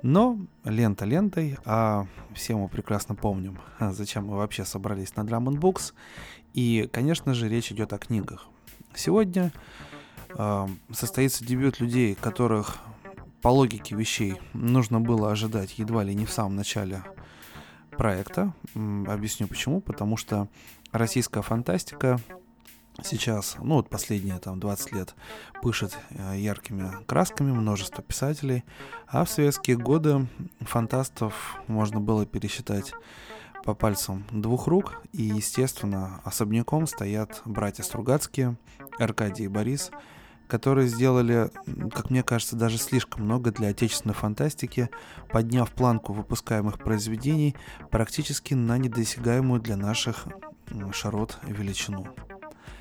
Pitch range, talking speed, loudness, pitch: 105-130 Hz, 115 wpm, -27 LUFS, 115 Hz